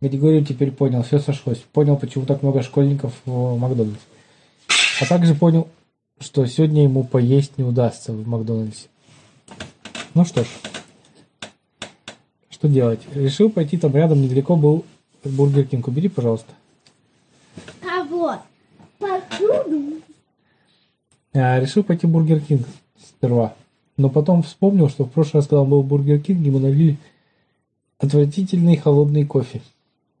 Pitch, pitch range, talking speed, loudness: 145 Hz, 130-160 Hz, 130 wpm, -18 LUFS